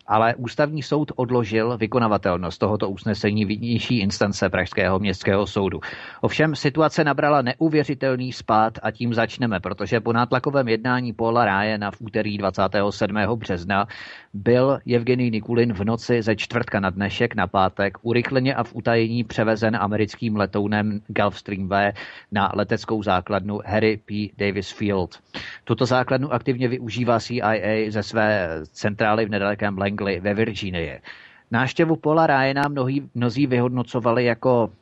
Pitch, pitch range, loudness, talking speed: 110 Hz, 100-125 Hz, -22 LUFS, 130 wpm